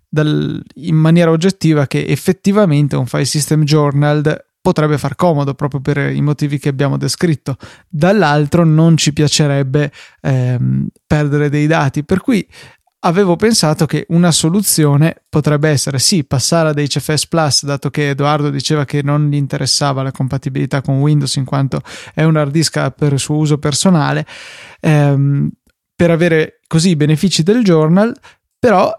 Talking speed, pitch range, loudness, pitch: 155 wpm, 140-165 Hz, -13 LUFS, 150 Hz